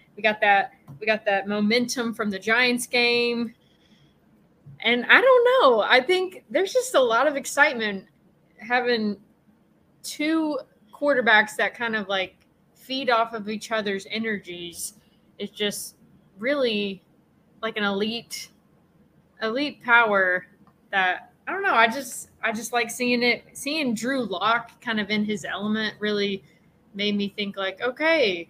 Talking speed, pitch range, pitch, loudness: 145 wpm, 200-245 Hz, 225 Hz, -23 LUFS